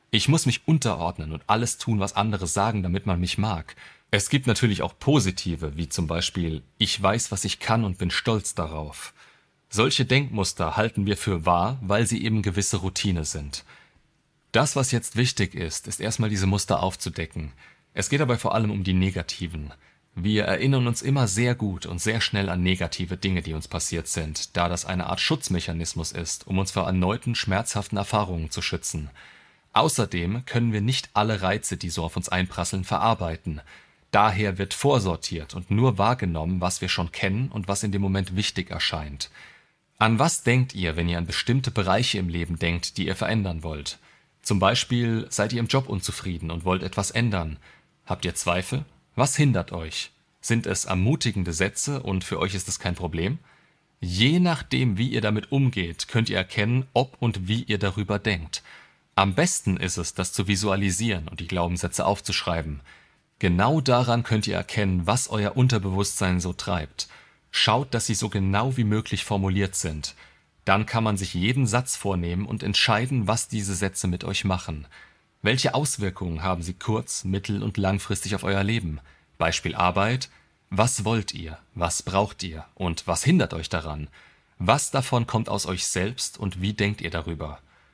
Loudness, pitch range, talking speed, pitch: -25 LUFS, 90-115 Hz, 175 wpm, 100 Hz